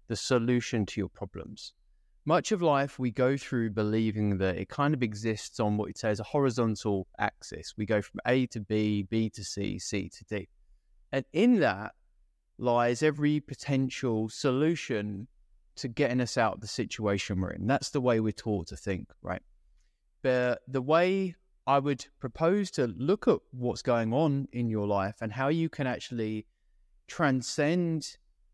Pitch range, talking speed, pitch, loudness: 105-140 Hz, 170 wpm, 115 Hz, -30 LUFS